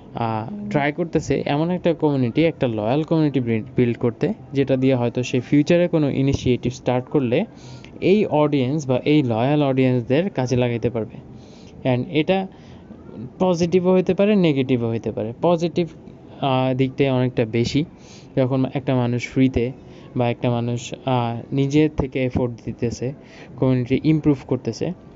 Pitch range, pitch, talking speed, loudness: 125-150 Hz, 135 Hz, 130 wpm, -21 LUFS